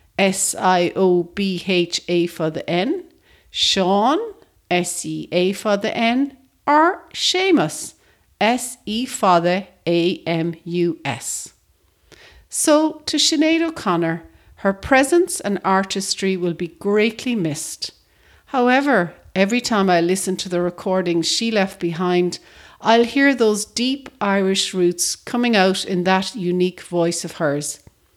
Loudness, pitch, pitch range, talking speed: -19 LUFS, 190 Hz, 175-240 Hz, 135 wpm